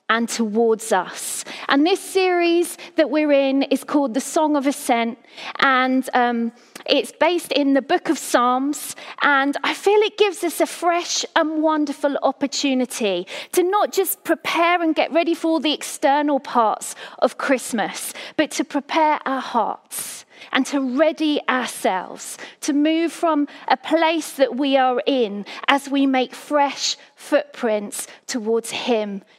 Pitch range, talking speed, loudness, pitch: 255-315 Hz, 150 wpm, -20 LUFS, 285 Hz